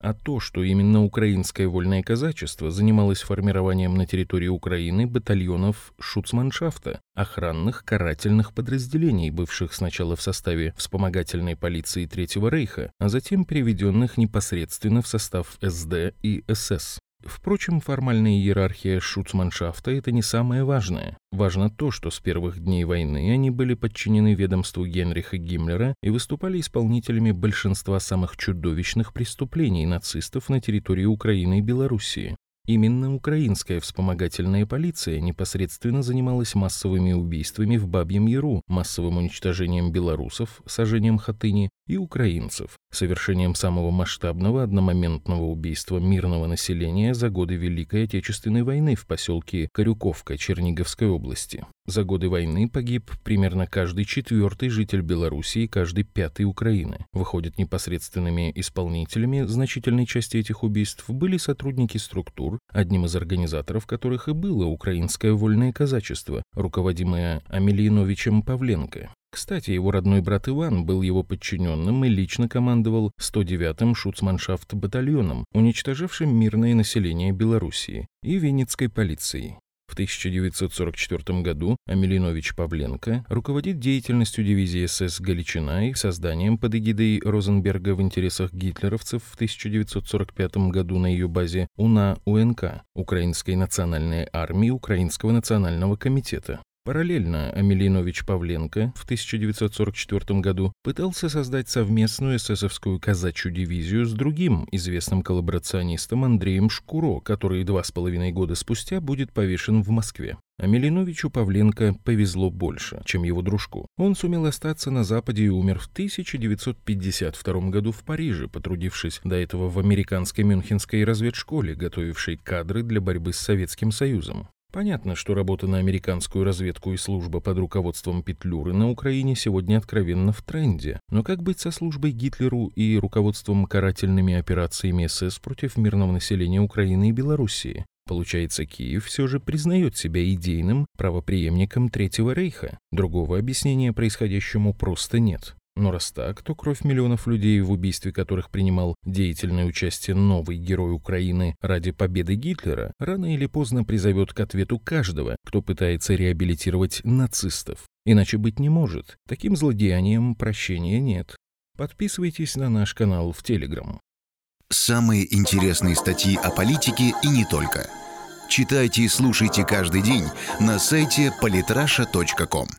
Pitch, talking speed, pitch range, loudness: 100 Hz, 125 wpm, 90-115 Hz, -24 LUFS